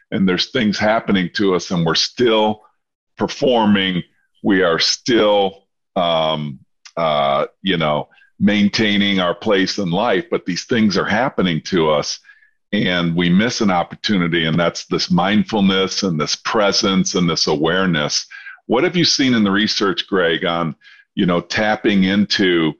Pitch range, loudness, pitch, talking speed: 85-105 Hz, -17 LUFS, 95 Hz, 150 wpm